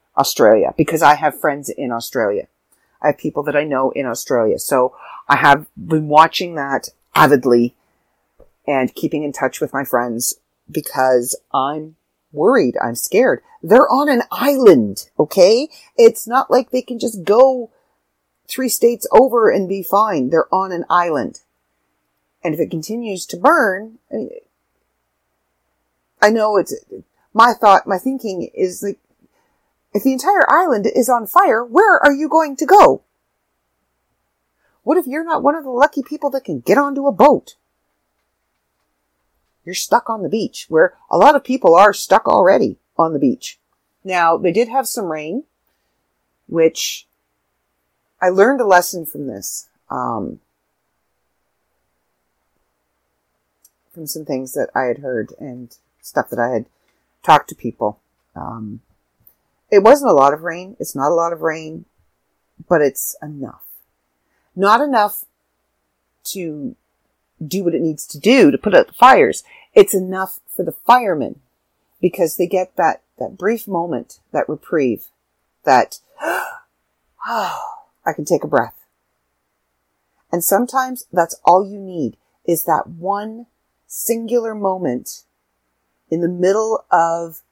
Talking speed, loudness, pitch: 145 wpm, -16 LUFS, 165 Hz